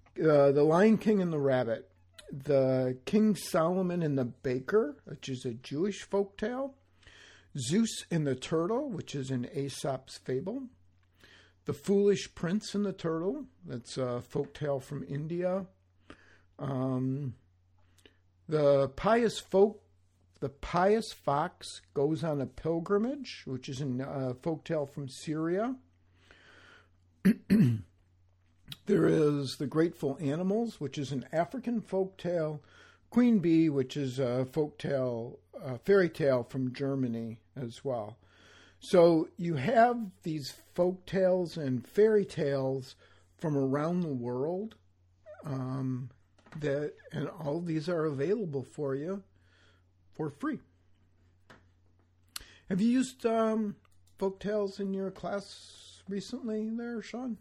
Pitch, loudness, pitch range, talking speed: 145 Hz, -31 LUFS, 120-190 Hz, 120 wpm